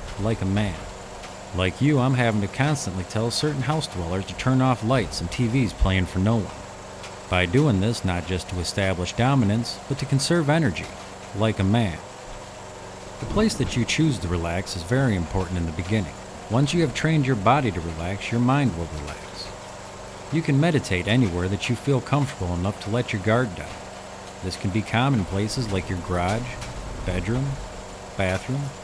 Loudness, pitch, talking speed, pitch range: -24 LUFS, 100 Hz, 180 wpm, 95-125 Hz